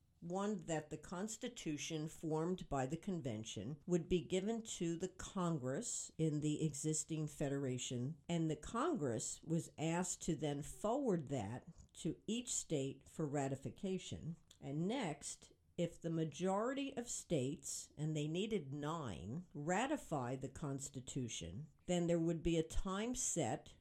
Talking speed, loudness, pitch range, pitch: 135 wpm, -42 LUFS, 145-180 Hz, 160 Hz